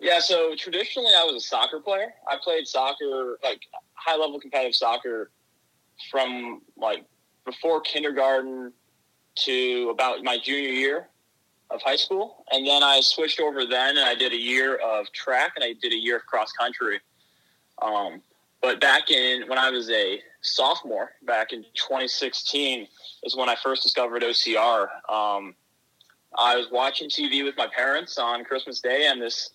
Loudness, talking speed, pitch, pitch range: -23 LUFS, 160 wpm, 135 Hz, 125-155 Hz